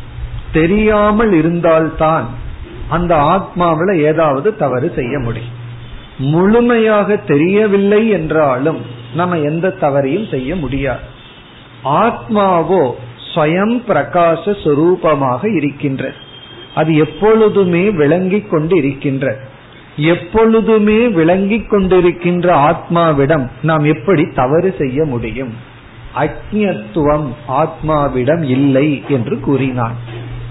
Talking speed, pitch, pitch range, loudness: 75 wpm, 155 Hz, 135-185 Hz, -13 LUFS